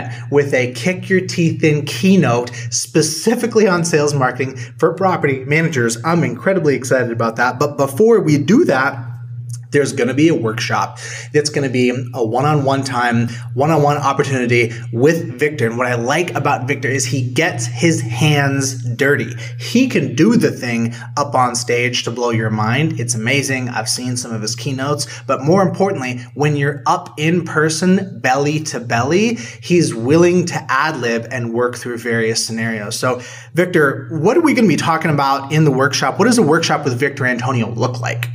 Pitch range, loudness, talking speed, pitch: 120-155 Hz, -16 LUFS, 180 wpm, 135 Hz